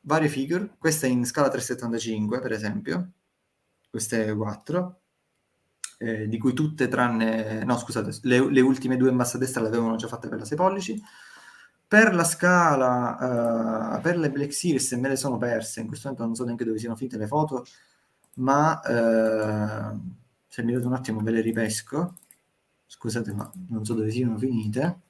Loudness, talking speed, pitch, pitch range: -25 LUFS, 175 wpm, 125 Hz, 115-145 Hz